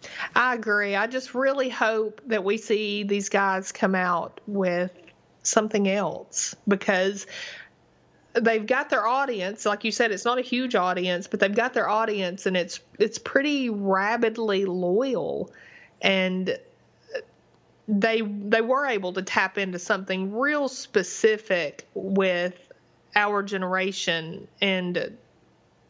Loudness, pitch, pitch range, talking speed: -25 LUFS, 205 Hz, 190-230 Hz, 125 wpm